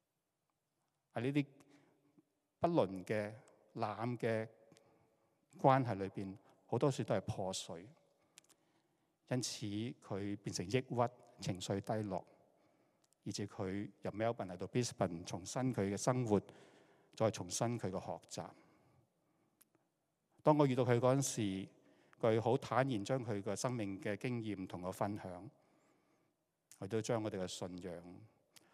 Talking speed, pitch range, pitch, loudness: 200 characters per minute, 100-125 Hz, 110 Hz, -39 LUFS